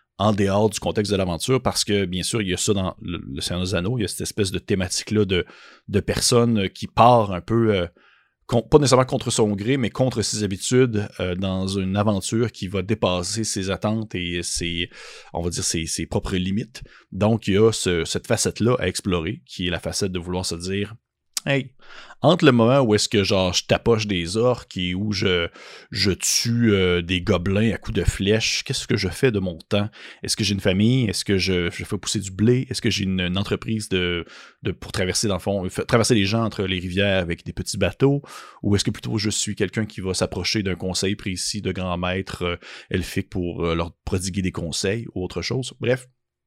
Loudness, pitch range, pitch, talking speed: -22 LUFS, 90-110 Hz, 100 Hz, 220 wpm